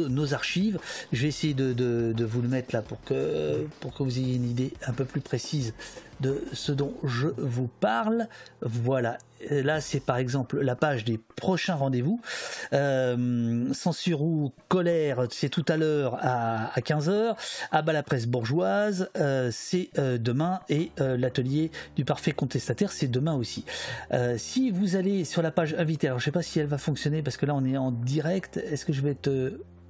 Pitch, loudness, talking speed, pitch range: 140 Hz, -28 LUFS, 205 wpm, 125-160 Hz